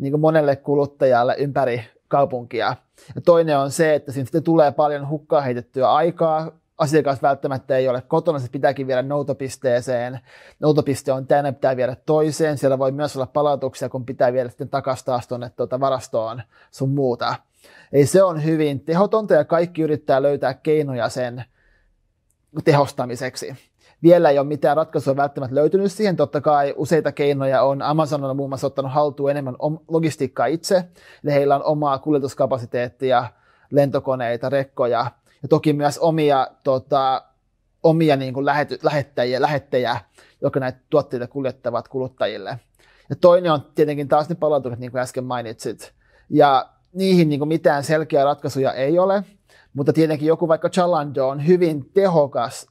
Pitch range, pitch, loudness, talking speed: 130-155 Hz, 140 Hz, -20 LUFS, 150 wpm